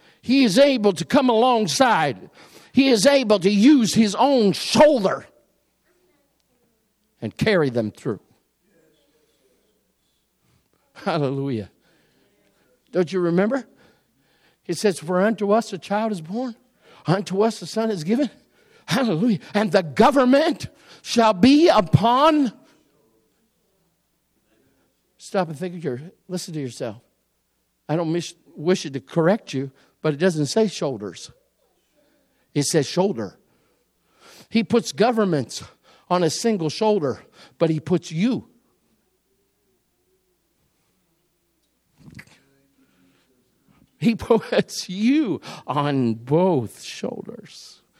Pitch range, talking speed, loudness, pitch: 160-230 Hz, 105 wpm, -21 LUFS, 190 Hz